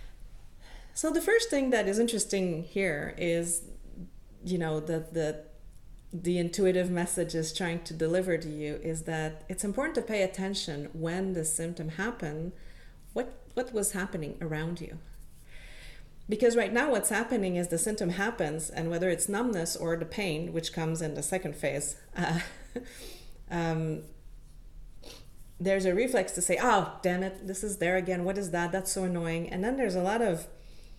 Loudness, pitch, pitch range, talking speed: -31 LUFS, 175 Hz, 165-195 Hz, 170 wpm